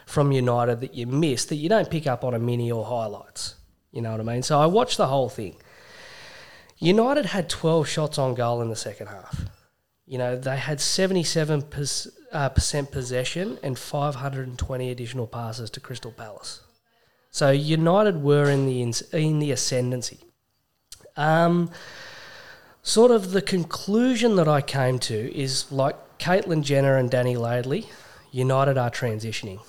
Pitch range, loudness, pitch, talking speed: 125-160 Hz, -24 LUFS, 135 Hz, 160 wpm